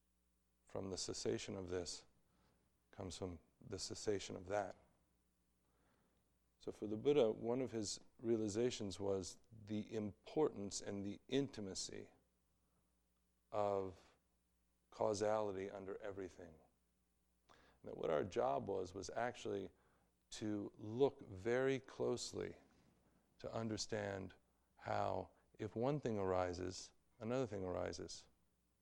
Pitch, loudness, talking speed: 95 Hz, -44 LUFS, 105 wpm